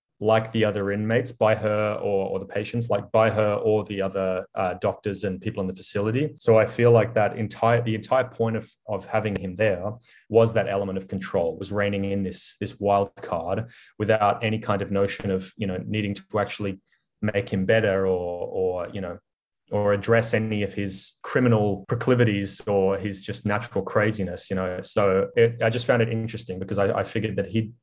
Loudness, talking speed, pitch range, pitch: -24 LUFS, 205 wpm, 100-110 Hz, 105 Hz